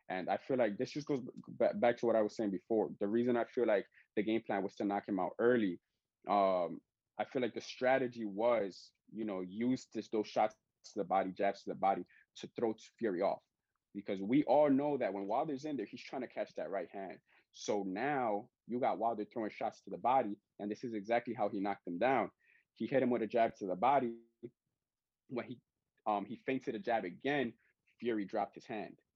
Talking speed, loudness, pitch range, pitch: 220 wpm, -36 LUFS, 100-120 Hz, 115 Hz